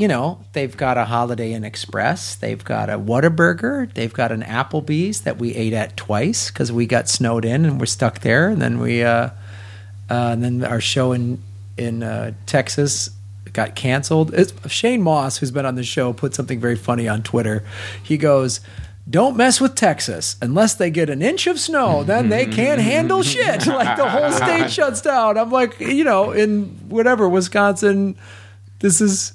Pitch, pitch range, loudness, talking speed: 120 Hz, 110-170 Hz, -18 LUFS, 190 wpm